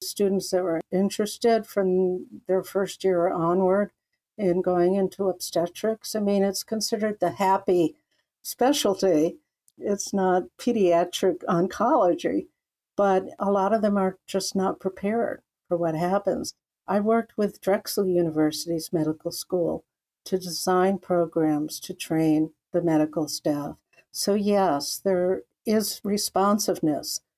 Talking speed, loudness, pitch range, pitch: 125 wpm, -25 LUFS, 175-200 Hz, 190 Hz